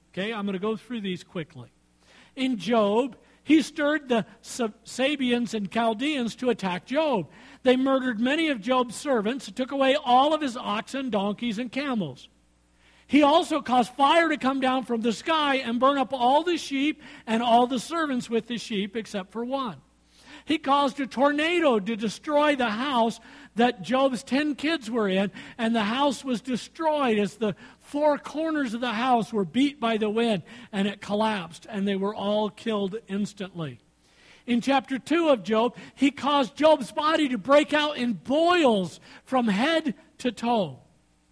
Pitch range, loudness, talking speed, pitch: 215-275 Hz, -25 LUFS, 175 wpm, 245 Hz